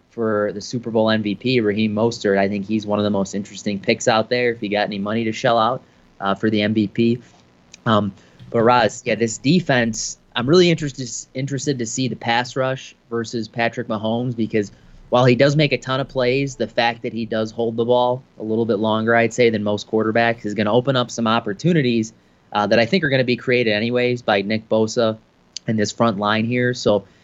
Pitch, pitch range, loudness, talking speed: 115 Hz, 105-125 Hz, -20 LUFS, 220 wpm